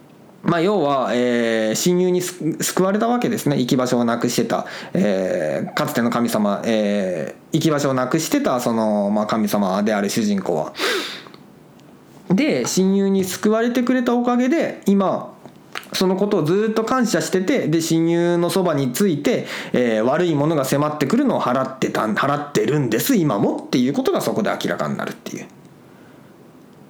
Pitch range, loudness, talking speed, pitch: 125-200 Hz, -19 LUFS, 305 characters per minute, 170 Hz